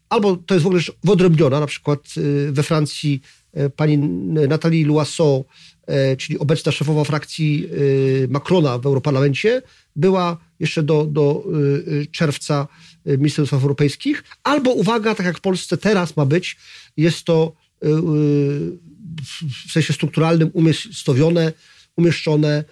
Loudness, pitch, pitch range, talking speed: -18 LUFS, 155 Hz, 145-170 Hz, 115 wpm